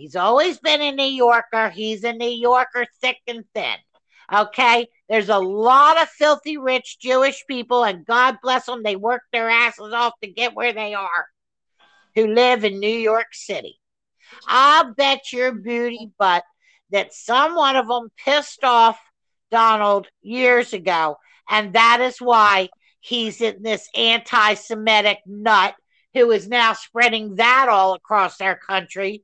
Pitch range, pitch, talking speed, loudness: 215-255 Hz, 235 Hz, 155 wpm, -18 LUFS